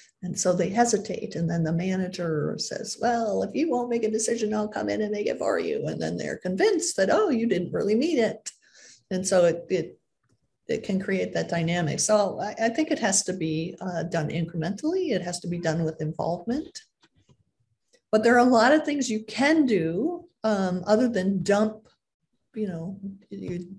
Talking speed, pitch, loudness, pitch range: 200 wpm, 200 Hz, -25 LUFS, 175-230 Hz